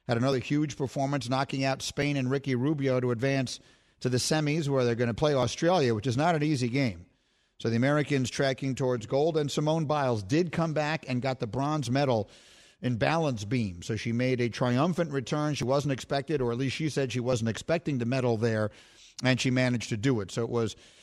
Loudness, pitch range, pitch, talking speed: -28 LUFS, 120-145 Hz, 130 Hz, 215 wpm